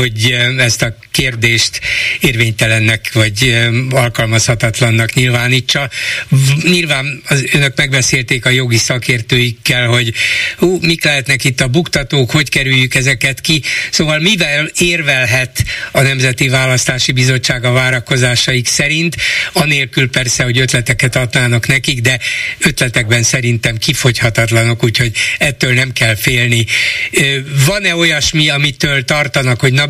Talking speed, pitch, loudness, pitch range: 110 wpm, 130 Hz, -11 LUFS, 120-145 Hz